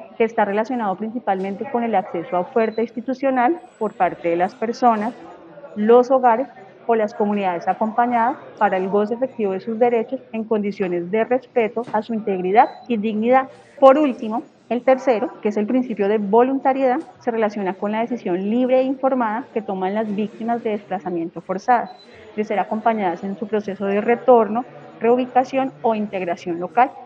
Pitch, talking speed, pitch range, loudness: 225 Hz, 165 wpm, 205-245 Hz, -20 LUFS